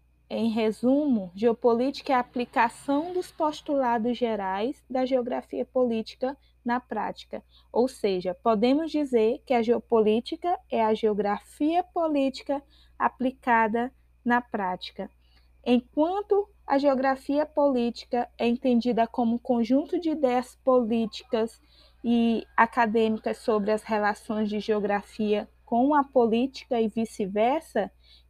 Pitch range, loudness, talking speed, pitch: 225-265 Hz, -26 LUFS, 110 wpm, 240 Hz